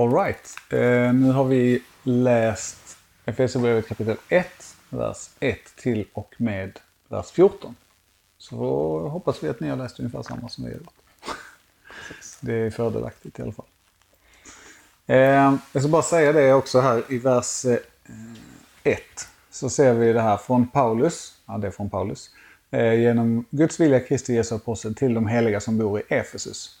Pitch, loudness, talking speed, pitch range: 115 Hz, -22 LUFS, 165 wpm, 110-130 Hz